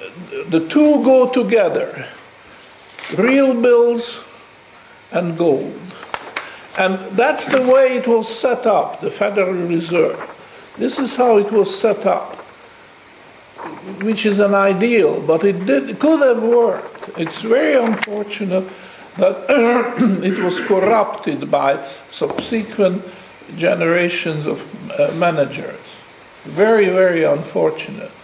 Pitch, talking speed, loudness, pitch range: 210 Hz, 110 wpm, -16 LUFS, 185-250 Hz